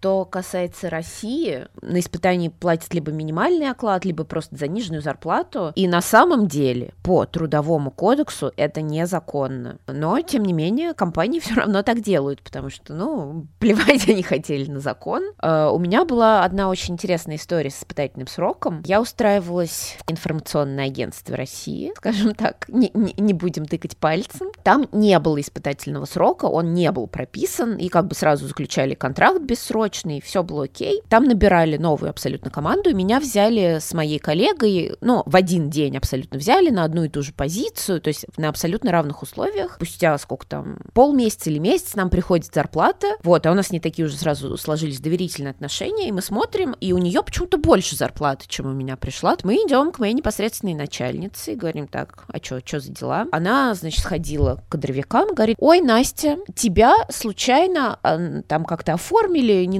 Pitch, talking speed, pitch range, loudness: 175 Hz, 175 wpm, 155-220 Hz, -20 LUFS